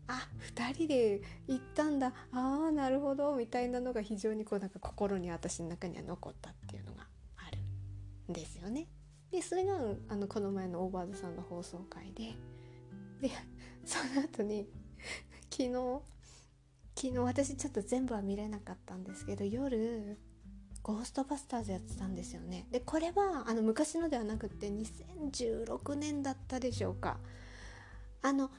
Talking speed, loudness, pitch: 260 characters per minute, -38 LUFS, 210 Hz